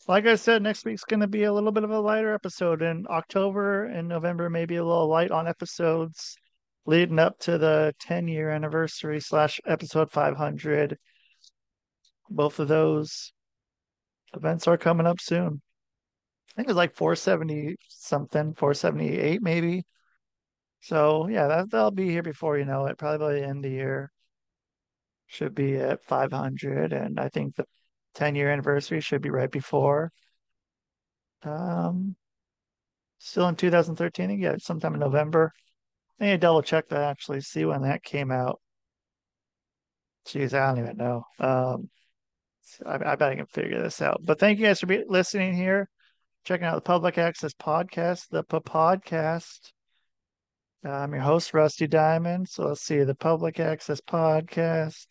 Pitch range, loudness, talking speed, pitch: 150-175 Hz, -26 LUFS, 165 wpm, 160 Hz